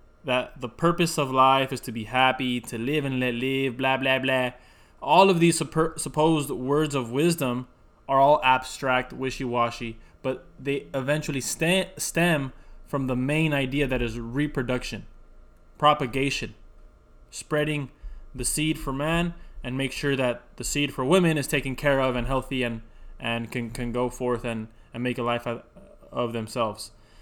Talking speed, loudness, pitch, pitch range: 170 wpm, -25 LUFS, 130 Hz, 120-145 Hz